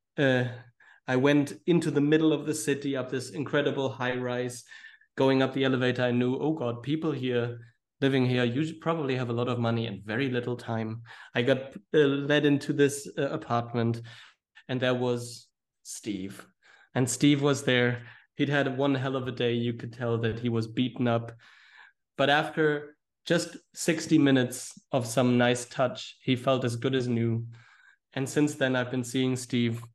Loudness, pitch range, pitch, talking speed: -28 LUFS, 120-145 Hz, 130 Hz, 180 wpm